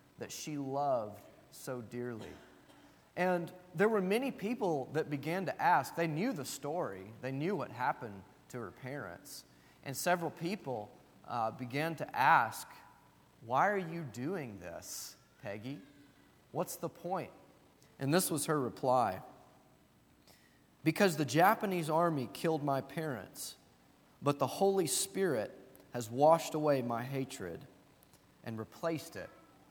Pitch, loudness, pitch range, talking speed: 150 Hz, -35 LUFS, 125-175 Hz, 130 wpm